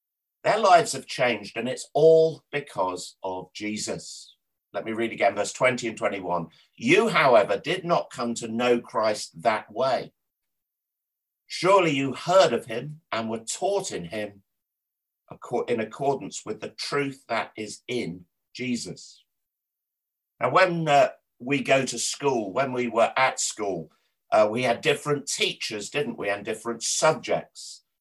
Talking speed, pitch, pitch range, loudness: 150 wpm, 120 Hz, 105-145 Hz, -25 LUFS